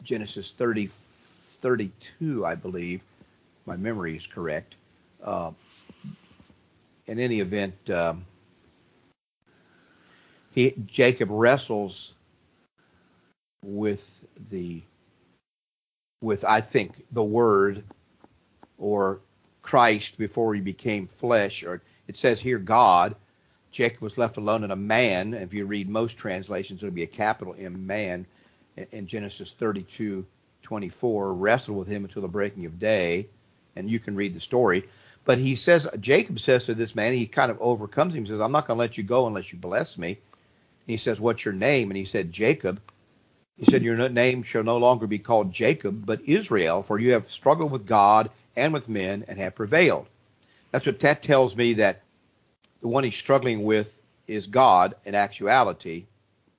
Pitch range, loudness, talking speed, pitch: 100-120 Hz, -24 LUFS, 155 wpm, 105 Hz